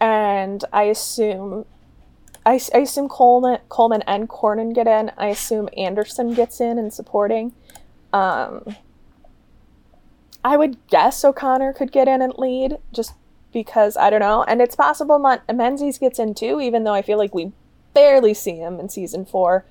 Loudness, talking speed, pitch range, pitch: -18 LUFS, 165 wpm, 210-255 Hz, 230 Hz